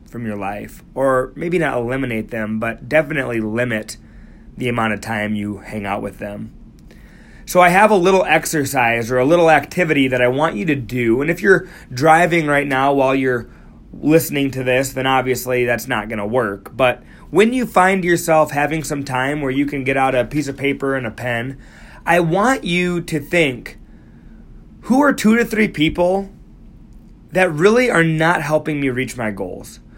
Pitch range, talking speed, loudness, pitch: 120-165 Hz, 190 wpm, -17 LUFS, 135 Hz